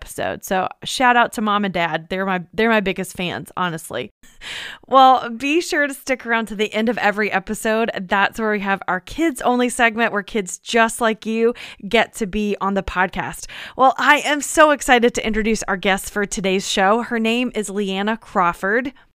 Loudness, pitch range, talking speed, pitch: -19 LUFS, 195-240 Hz, 195 wpm, 220 Hz